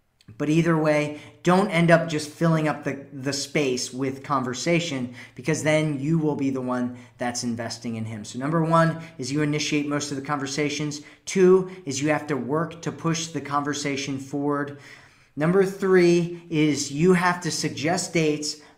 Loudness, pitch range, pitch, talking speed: -24 LUFS, 135-165 Hz, 150 Hz, 175 wpm